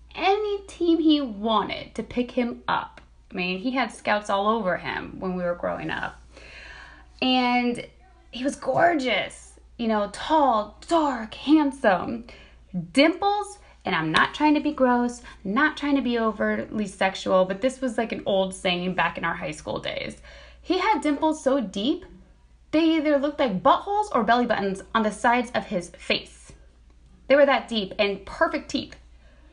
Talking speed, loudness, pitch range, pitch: 170 wpm, -24 LUFS, 195-290 Hz, 240 Hz